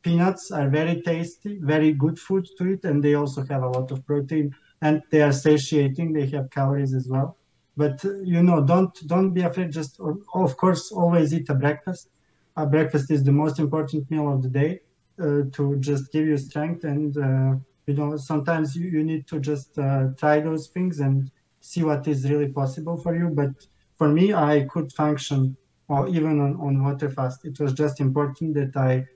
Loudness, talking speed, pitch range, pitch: -23 LUFS, 205 wpm, 140-165 Hz, 150 Hz